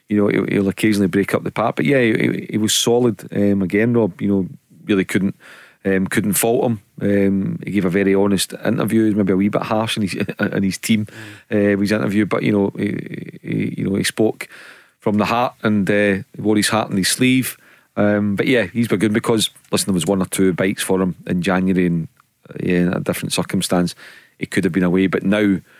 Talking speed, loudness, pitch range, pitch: 225 wpm, -18 LUFS, 95-110 Hz, 100 Hz